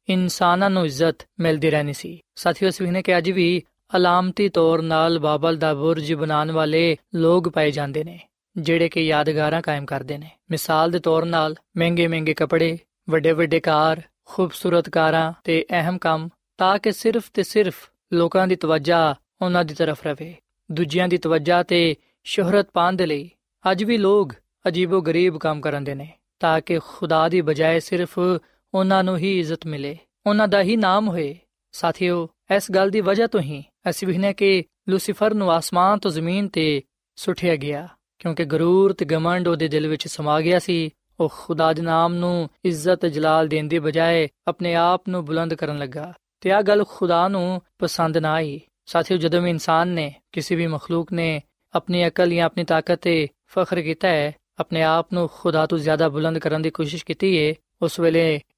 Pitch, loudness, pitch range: 170 Hz, -21 LUFS, 160-180 Hz